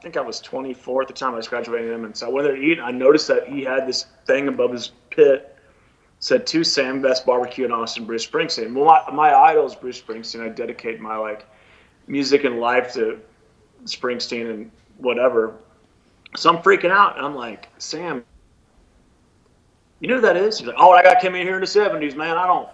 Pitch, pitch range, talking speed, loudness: 130 Hz, 115-180 Hz, 215 wpm, -19 LUFS